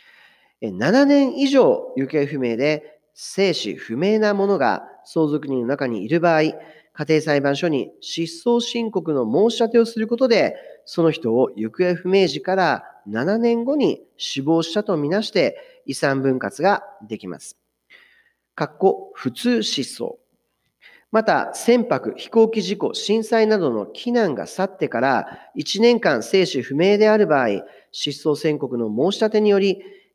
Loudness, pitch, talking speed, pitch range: -20 LUFS, 195 Hz, 255 characters per minute, 150-235 Hz